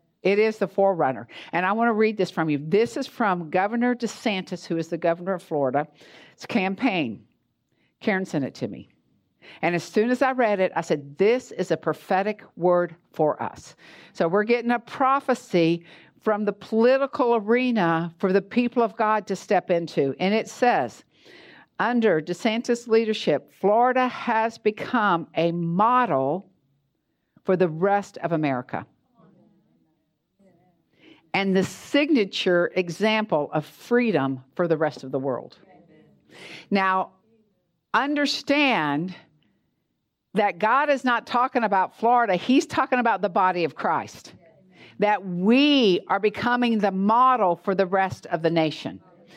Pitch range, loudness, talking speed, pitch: 170-230 Hz, -23 LUFS, 145 wpm, 195 Hz